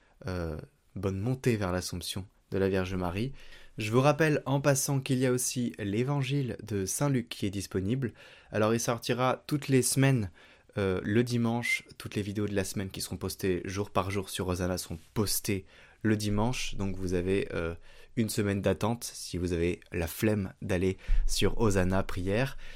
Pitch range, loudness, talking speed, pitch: 95-120 Hz, -31 LUFS, 175 wpm, 100 Hz